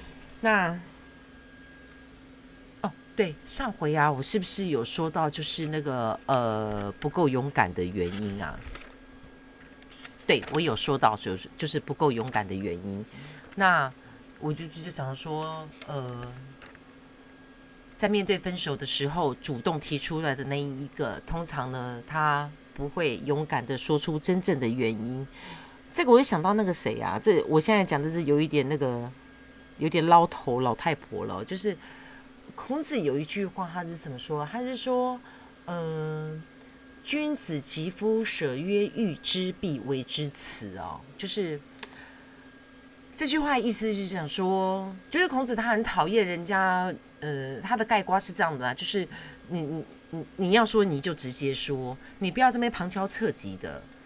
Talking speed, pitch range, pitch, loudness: 220 characters per minute, 140-200 Hz, 160 Hz, -28 LUFS